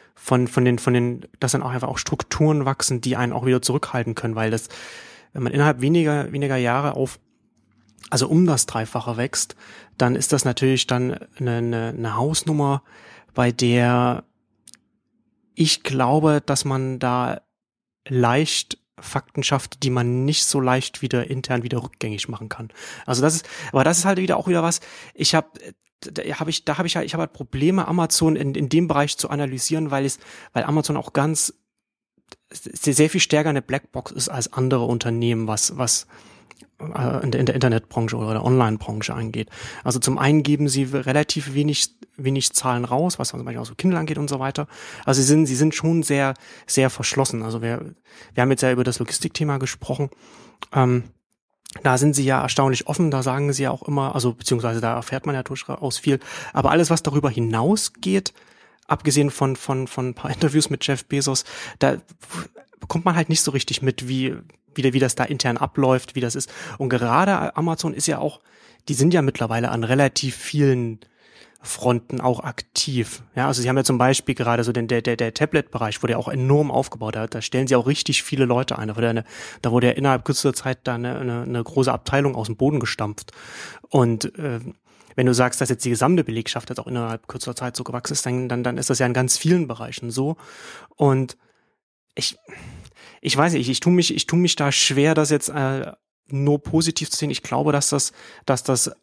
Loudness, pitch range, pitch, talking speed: -21 LUFS, 125-150 Hz, 135 Hz, 200 wpm